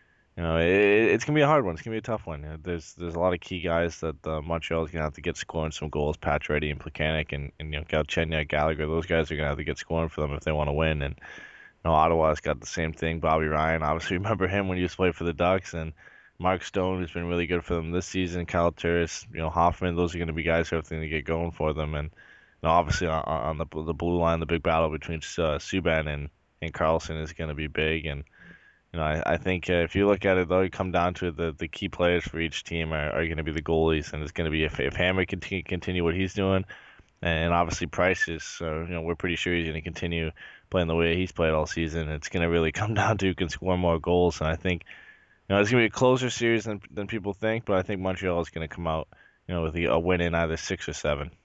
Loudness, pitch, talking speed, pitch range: -27 LUFS, 85 Hz, 290 wpm, 80-90 Hz